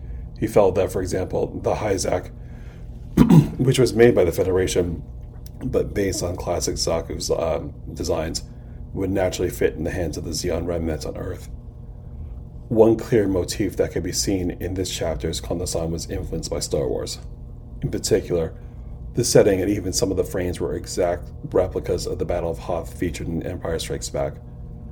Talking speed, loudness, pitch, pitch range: 175 wpm, -22 LUFS, 85 Hz, 75-95 Hz